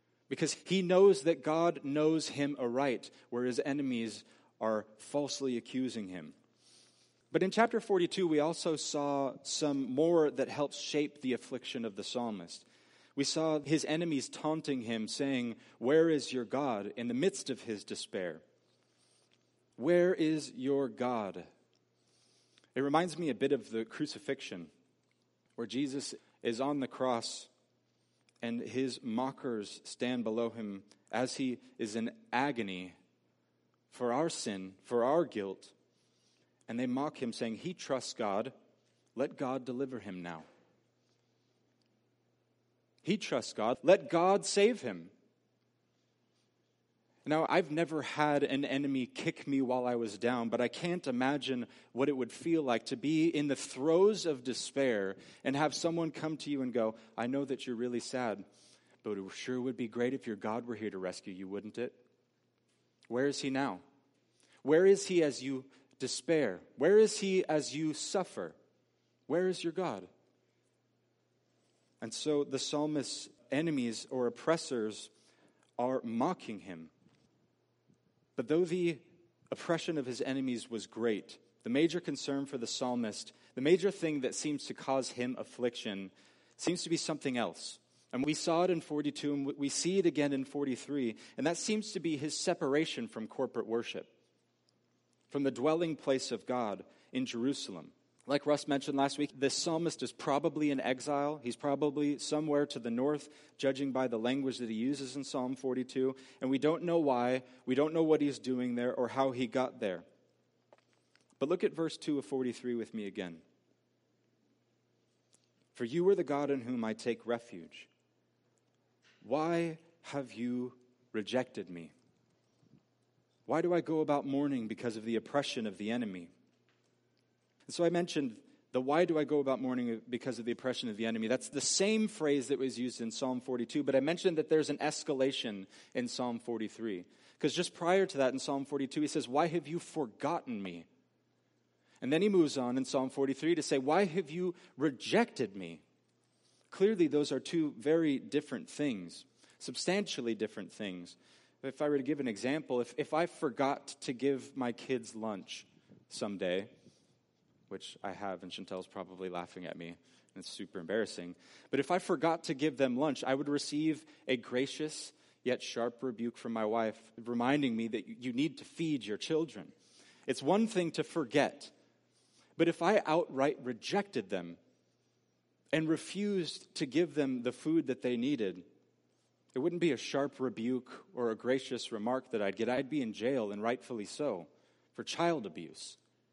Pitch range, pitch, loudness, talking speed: 120-155 Hz, 135 Hz, -34 LUFS, 165 wpm